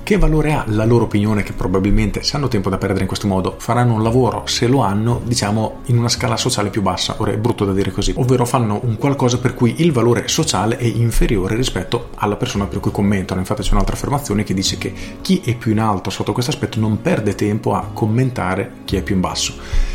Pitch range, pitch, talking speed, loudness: 100-120 Hz, 110 Hz, 230 wpm, -18 LUFS